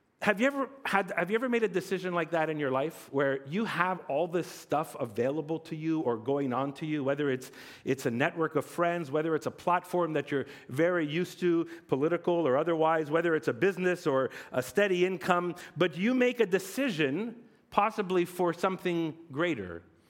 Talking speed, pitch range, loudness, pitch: 195 wpm, 145-185 Hz, -30 LUFS, 170 Hz